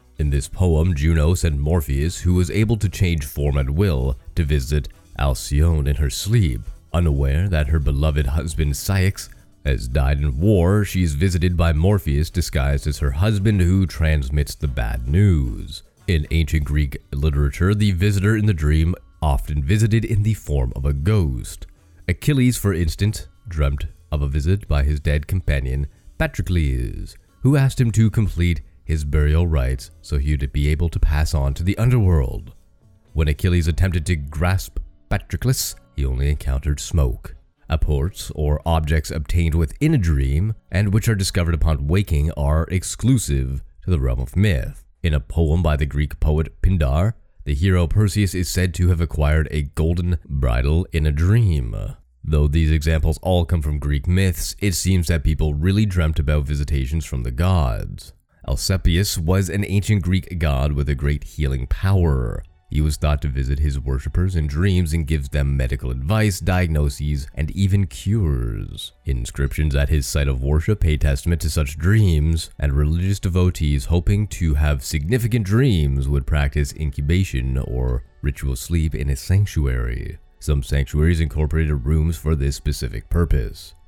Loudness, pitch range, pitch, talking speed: -21 LUFS, 75-90 Hz, 80 Hz, 165 wpm